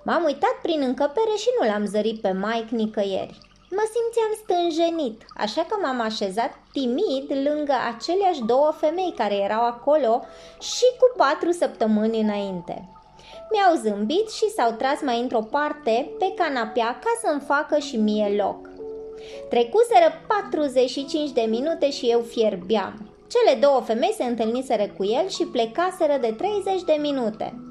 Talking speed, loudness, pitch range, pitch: 145 wpm, -23 LUFS, 225-350 Hz, 280 Hz